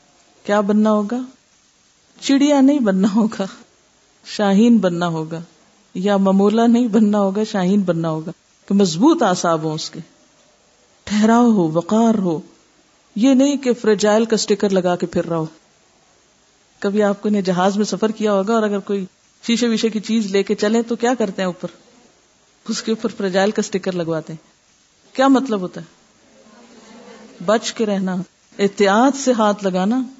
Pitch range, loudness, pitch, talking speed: 190-230 Hz, -17 LUFS, 210 Hz, 160 wpm